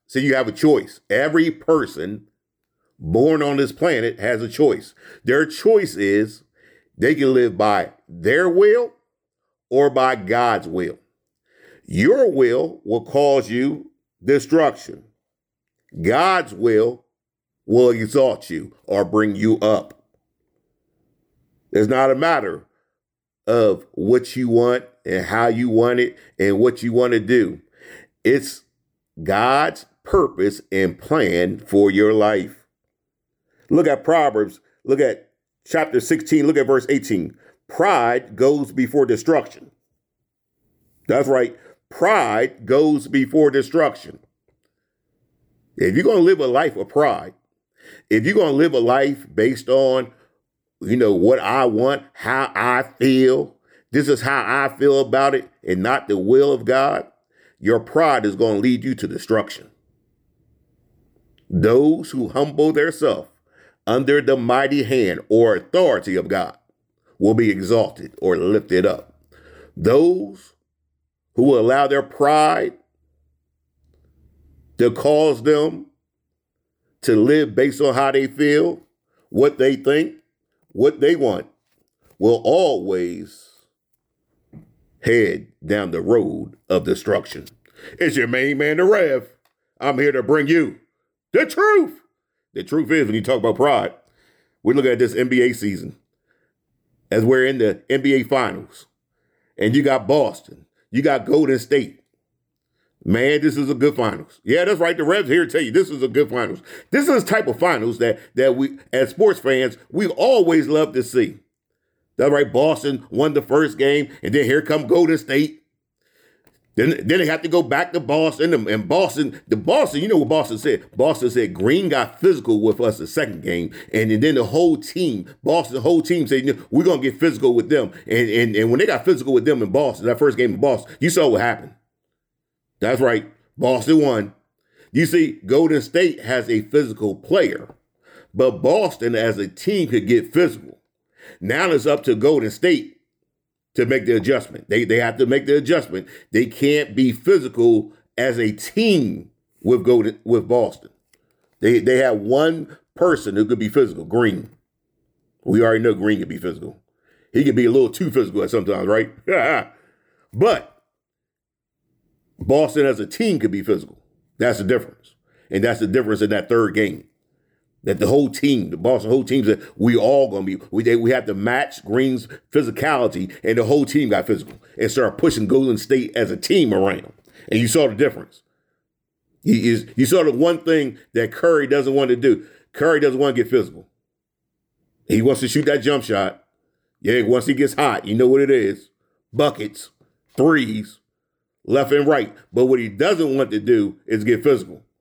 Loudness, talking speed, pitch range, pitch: -18 LUFS, 160 wpm, 115-165 Hz, 135 Hz